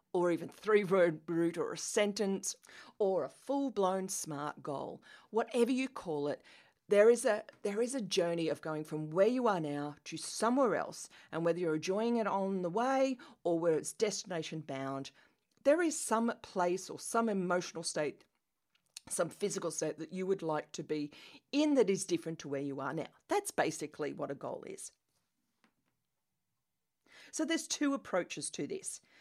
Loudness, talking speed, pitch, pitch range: -35 LUFS, 175 wpm, 190 Hz, 160-235 Hz